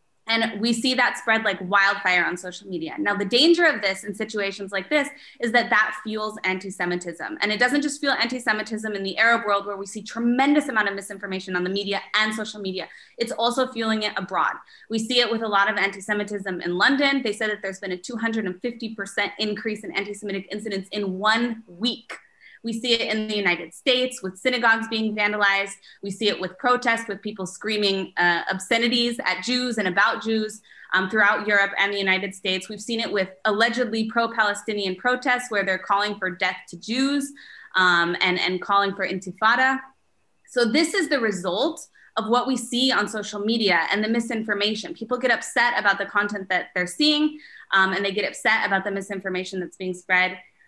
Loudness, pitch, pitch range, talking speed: -23 LUFS, 210 Hz, 195-235 Hz, 195 wpm